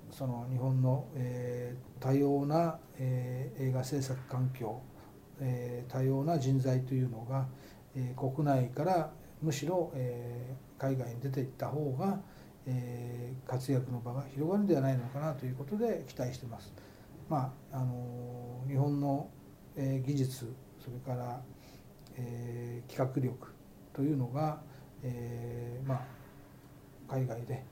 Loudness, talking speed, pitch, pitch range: -35 LUFS, 250 characters per minute, 130 Hz, 125-140 Hz